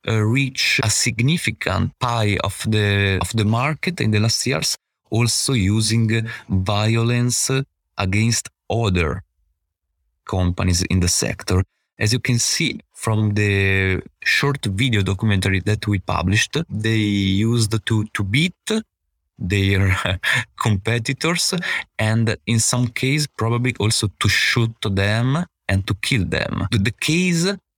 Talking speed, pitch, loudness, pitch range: 125 wpm, 110 Hz, -19 LUFS, 95-120 Hz